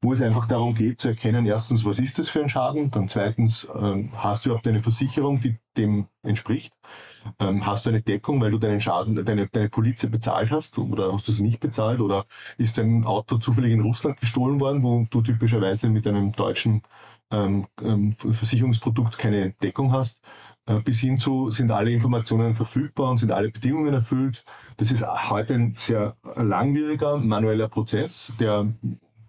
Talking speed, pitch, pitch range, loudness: 180 wpm, 115 Hz, 105-125 Hz, -24 LUFS